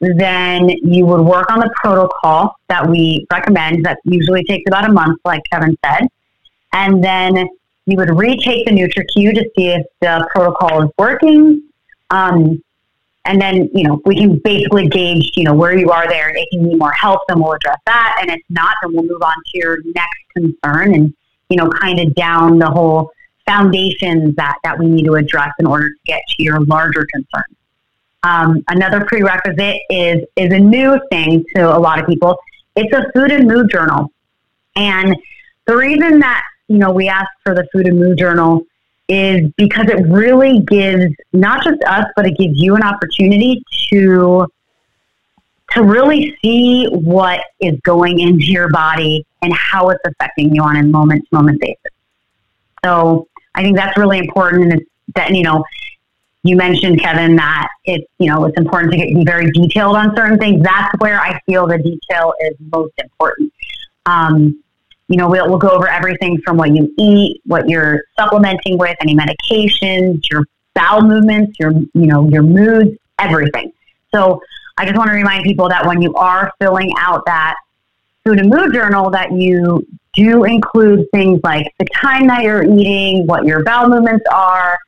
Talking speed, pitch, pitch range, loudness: 180 wpm, 180 Hz, 165-200 Hz, -11 LUFS